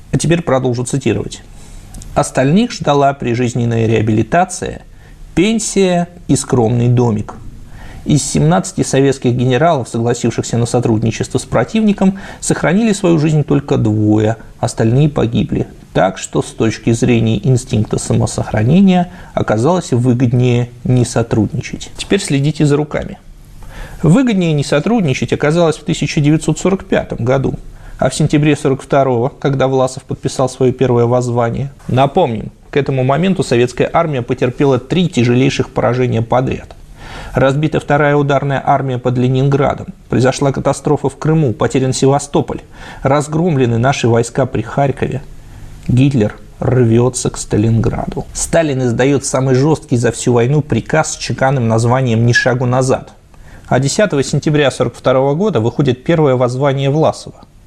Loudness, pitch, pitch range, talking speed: -14 LUFS, 130 Hz, 120-150 Hz, 120 wpm